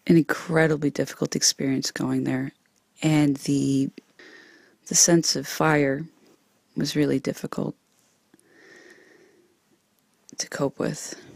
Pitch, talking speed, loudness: 165 Hz, 95 wpm, -23 LUFS